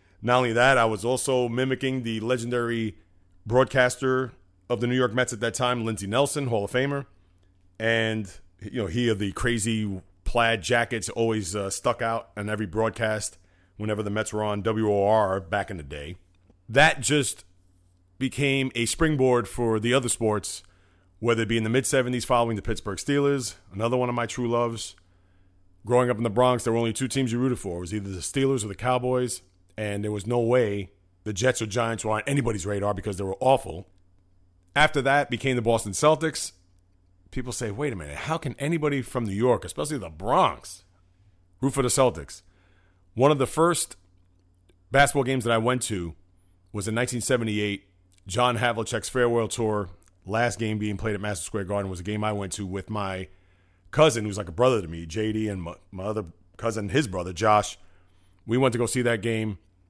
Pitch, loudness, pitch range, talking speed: 110 Hz, -25 LUFS, 95-125 Hz, 195 wpm